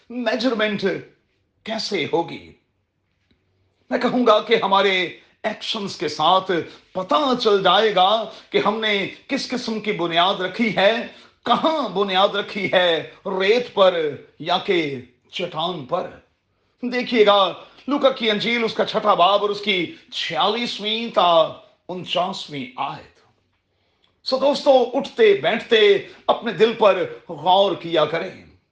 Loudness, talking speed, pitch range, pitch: -20 LUFS, 125 wpm, 185-240 Hz, 210 Hz